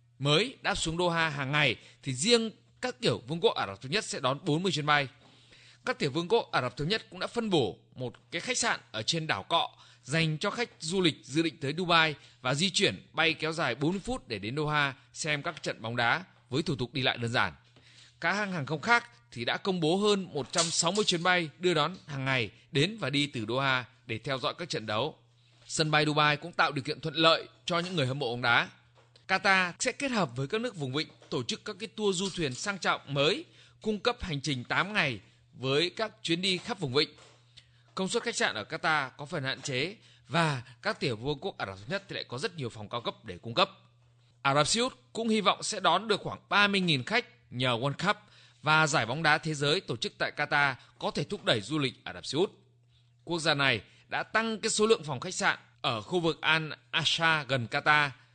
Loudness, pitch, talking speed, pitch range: -29 LUFS, 150 Hz, 240 wpm, 125-180 Hz